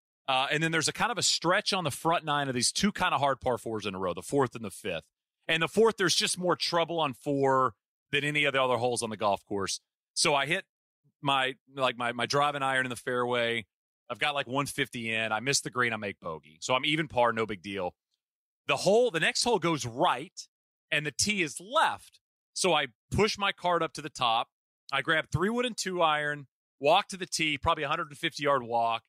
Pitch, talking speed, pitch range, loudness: 145 Hz, 235 wpm, 125-165 Hz, -28 LUFS